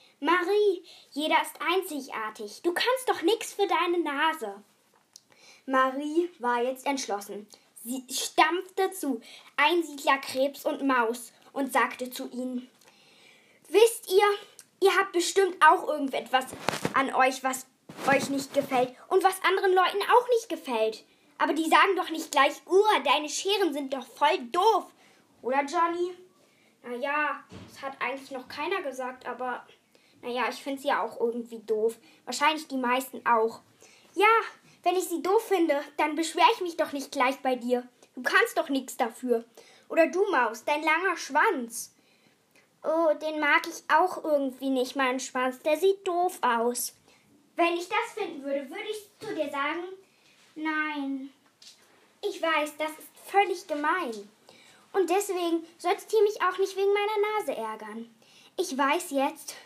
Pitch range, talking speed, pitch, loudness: 260-360 Hz, 150 wpm, 300 Hz, -27 LUFS